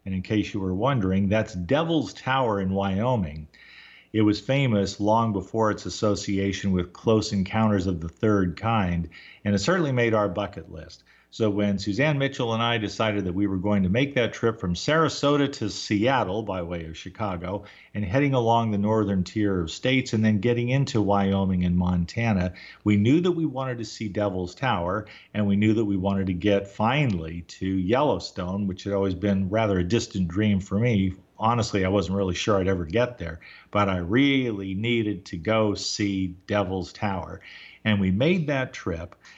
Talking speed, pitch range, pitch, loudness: 185 wpm, 95-110 Hz, 100 Hz, -25 LUFS